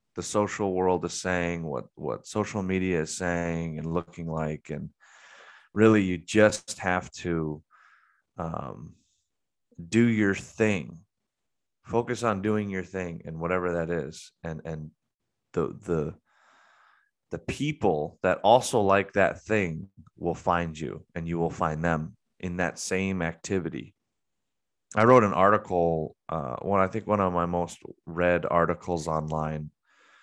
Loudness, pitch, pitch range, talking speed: -27 LUFS, 90 Hz, 85-100 Hz, 140 wpm